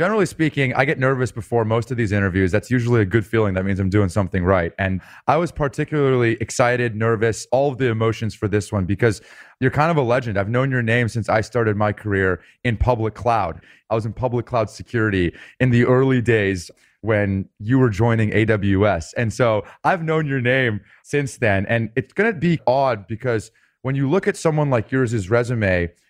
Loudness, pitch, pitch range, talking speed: -20 LUFS, 115 Hz, 105-130 Hz, 205 wpm